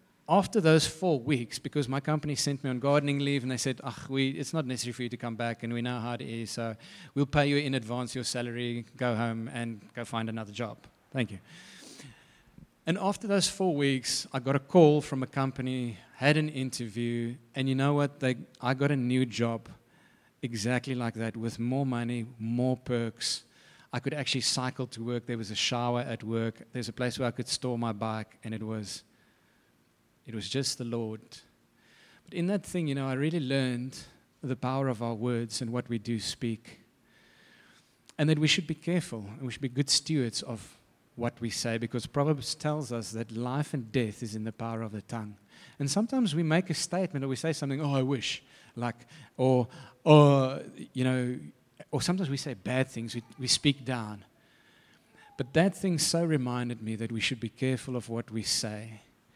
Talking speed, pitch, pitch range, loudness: 205 wpm, 125 Hz, 115-145 Hz, -30 LUFS